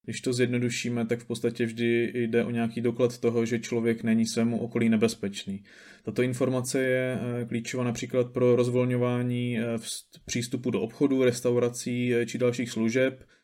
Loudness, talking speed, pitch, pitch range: -27 LUFS, 145 wpm, 120 Hz, 115-125 Hz